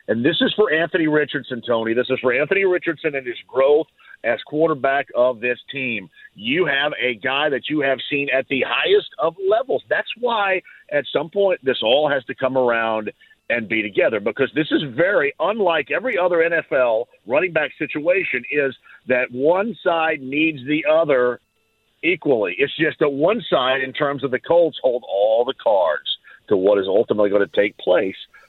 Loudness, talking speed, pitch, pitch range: -20 LUFS, 185 wpm, 150 Hz, 130-195 Hz